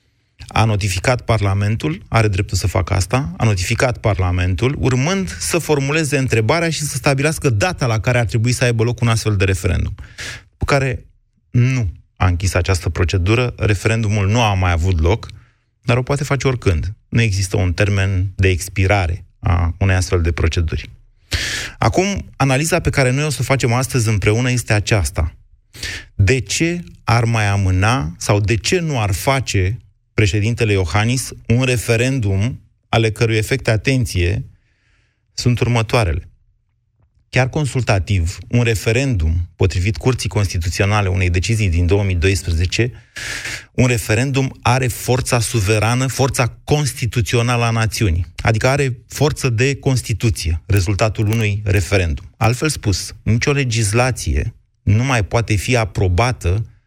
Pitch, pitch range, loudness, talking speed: 110 Hz, 100-125 Hz, -17 LUFS, 135 wpm